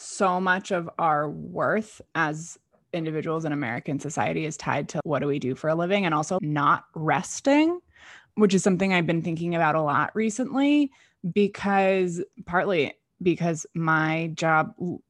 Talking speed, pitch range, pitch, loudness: 155 wpm, 155-195 Hz, 170 Hz, -25 LUFS